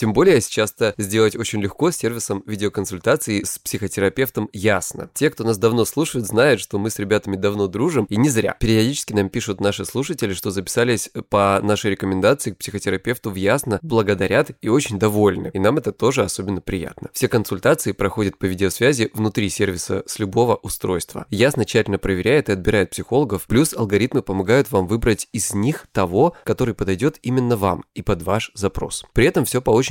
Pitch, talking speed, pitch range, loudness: 105 Hz, 175 wpm, 100-115 Hz, -20 LUFS